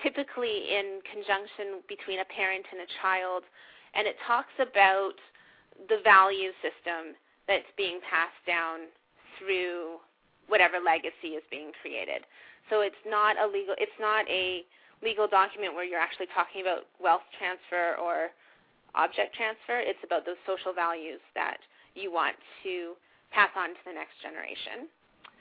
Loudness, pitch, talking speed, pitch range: -29 LUFS, 190 Hz, 145 wpm, 180-210 Hz